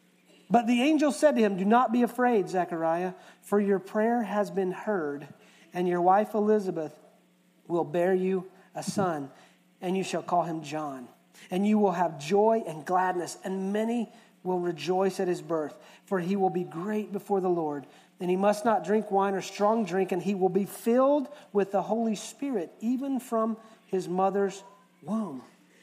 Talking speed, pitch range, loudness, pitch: 180 wpm, 180-215 Hz, -28 LUFS, 195 Hz